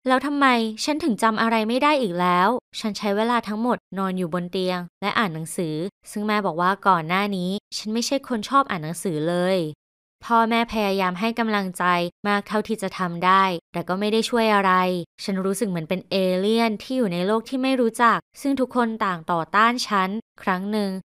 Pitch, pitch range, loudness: 205 Hz, 185-230 Hz, -22 LUFS